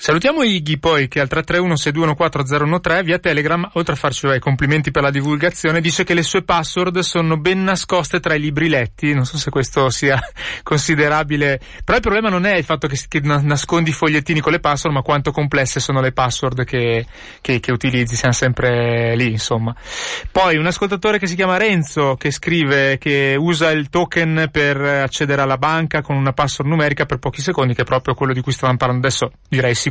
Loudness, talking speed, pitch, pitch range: -17 LUFS, 195 wpm, 150 Hz, 135-170 Hz